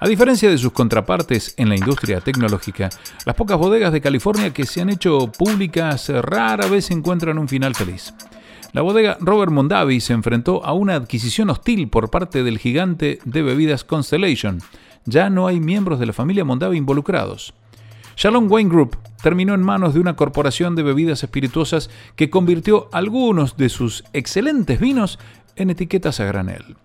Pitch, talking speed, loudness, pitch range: 150 Hz, 165 wpm, -18 LUFS, 120-185 Hz